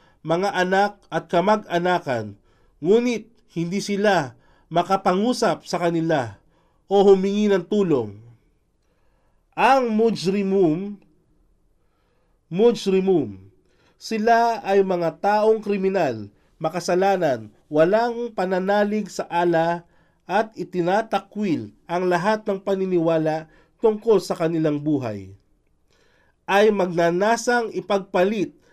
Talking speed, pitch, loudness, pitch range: 85 wpm, 185 Hz, -21 LUFS, 160-205 Hz